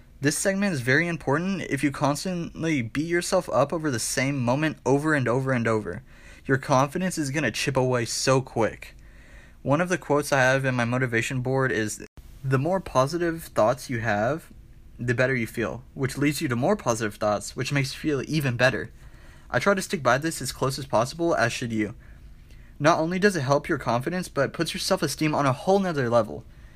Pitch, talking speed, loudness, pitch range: 135 Hz, 210 wpm, -25 LUFS, 120-160 Hz